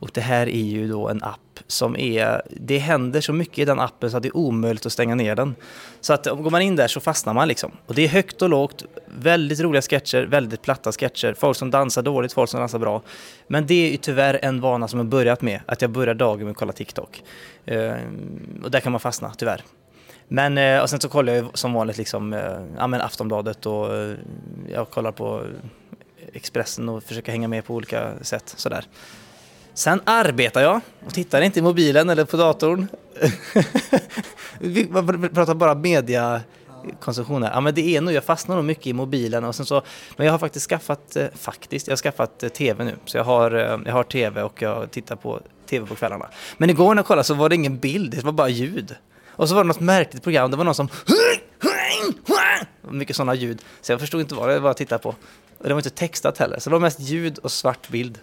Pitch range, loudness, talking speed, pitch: 120-160 Hz, -21 LUFS, 215 wpm, 140 Hz